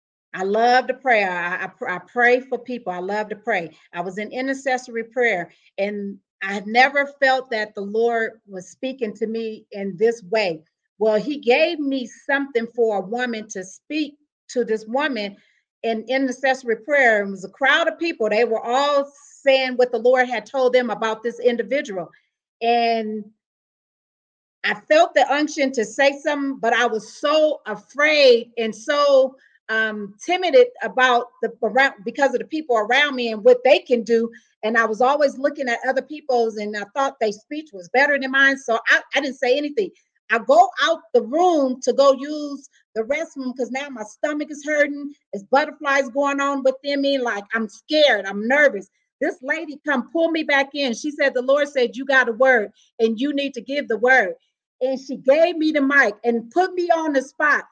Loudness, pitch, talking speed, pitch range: -20 LUFS, 255 Hz, 195 wpm, 225-280 Hz